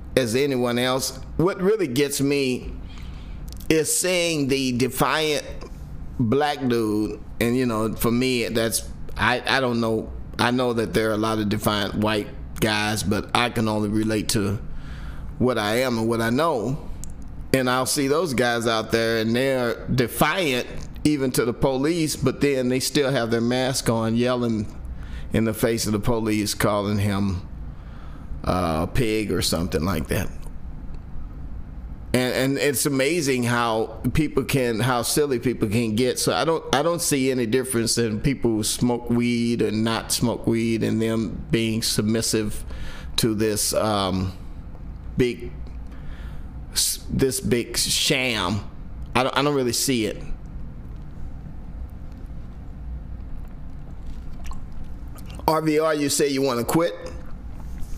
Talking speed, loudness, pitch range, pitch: 145 wpm, -22 LUFS, 85-125 Hz, 115 Hz